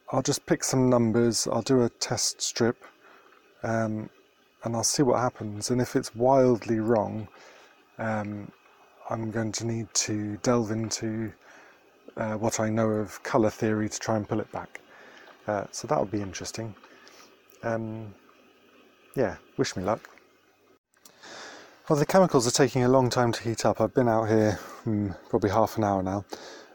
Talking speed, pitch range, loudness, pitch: 165 wpm, 110-120 Hz, -27 LUFS, 115 Hz